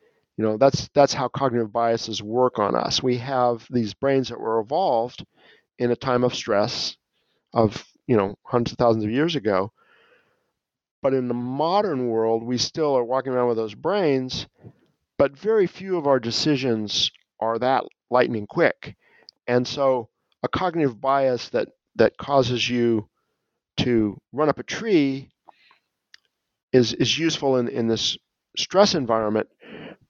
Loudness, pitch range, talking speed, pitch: -23 LUFS, 115-140 Hz, 150 wpm, 125 Hz